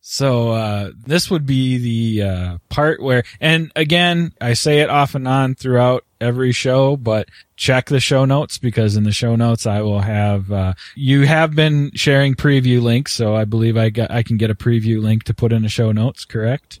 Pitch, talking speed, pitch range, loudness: 120 Hz, 205 wpm, 110-140 Hz, -16 LUFS